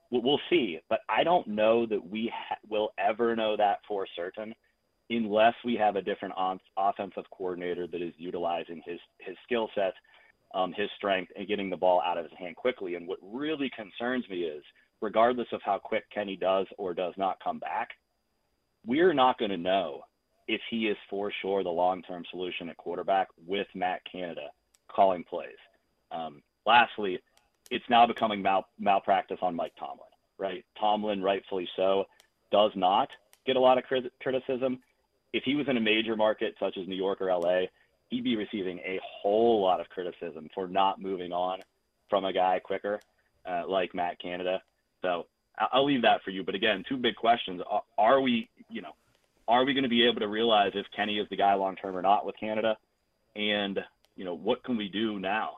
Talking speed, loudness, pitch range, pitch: 195 wpm, -29 LUFS, 95-115 Hz, 105 Hz